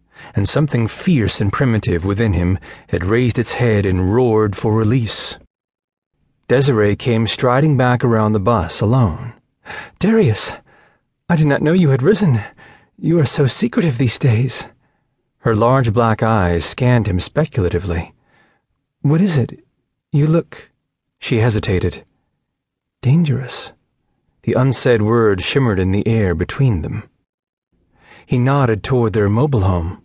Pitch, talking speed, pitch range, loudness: 115 Hz, 135 wpm, 105-135 Hz, -16 LUFS